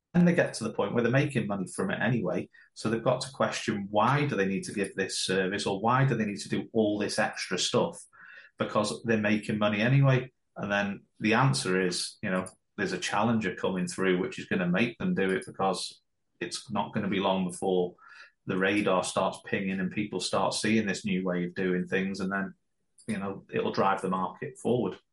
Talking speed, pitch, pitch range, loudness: 220 wpm, 100 Hz, 95-110 Hz, -29 LUFS